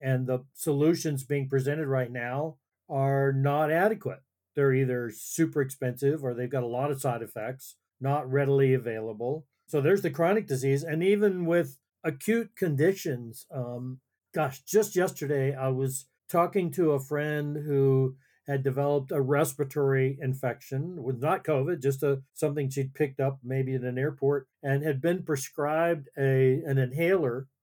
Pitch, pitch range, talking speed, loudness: 140 Hz, 130-155 Hz, 155 wpm, -28 LUFS